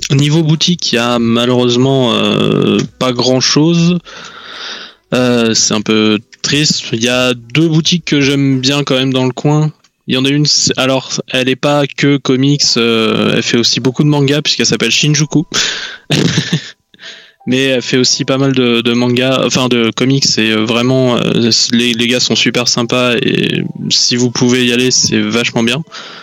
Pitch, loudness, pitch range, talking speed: 130 Hz, -11 LUFS, 120-150 Hz, 180 wpm